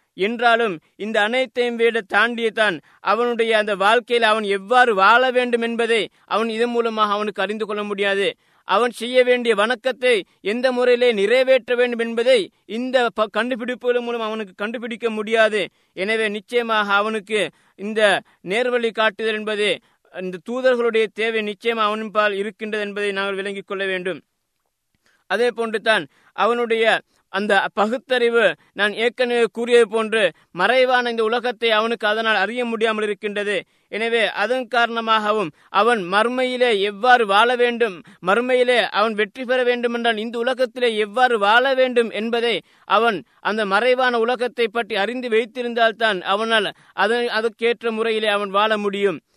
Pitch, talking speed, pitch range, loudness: 225 Hz, 125 wpm, 210-245 Hz, -19 LUFS